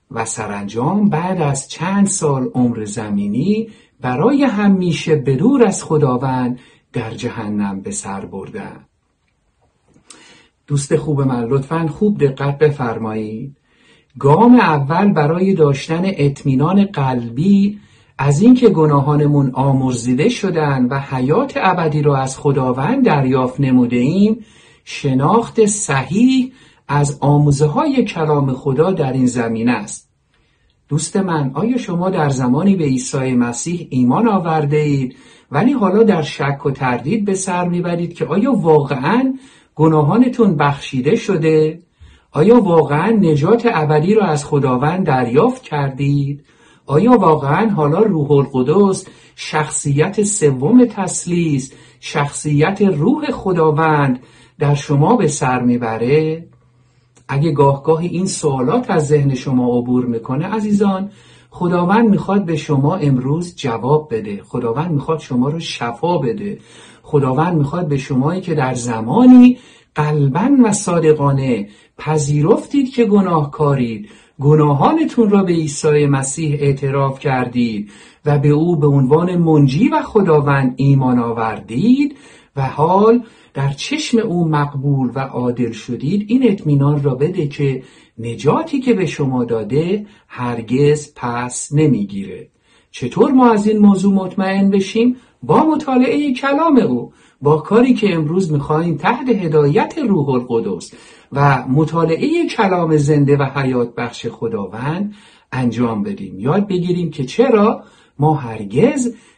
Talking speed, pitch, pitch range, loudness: 120 wpm, 155 Hz, 135-200 Hz, -15 LUFS